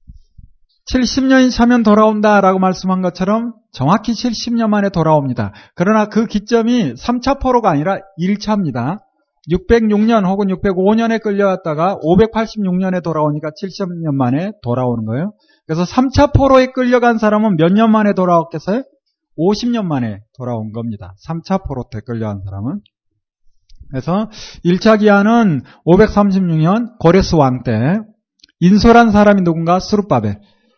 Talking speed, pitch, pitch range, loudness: 275 characters per minute, 195 Hz, 155-220 Hz, -14 LUFS